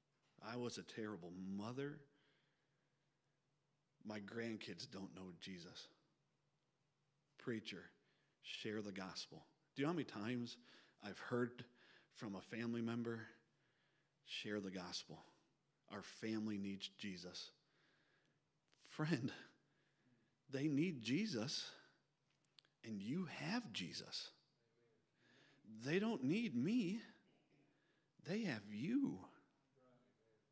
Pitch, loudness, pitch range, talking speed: 120 Hz, -47 LUFS, 110-150 Hz, 95 wpm